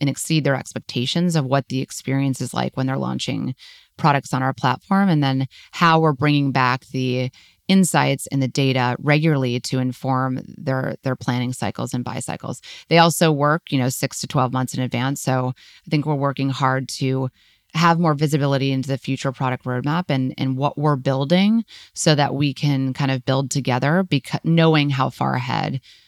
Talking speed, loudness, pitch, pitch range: 190 wpm, -20 LUFS, 135 Hz, 130-150 Hz